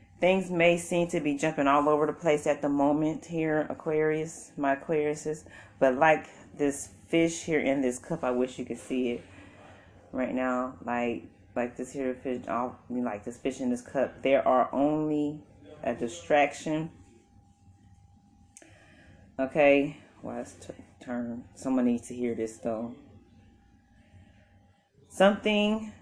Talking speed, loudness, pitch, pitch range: 145 wpm, -28 LUFS, 130 Hz, 115-155 Hz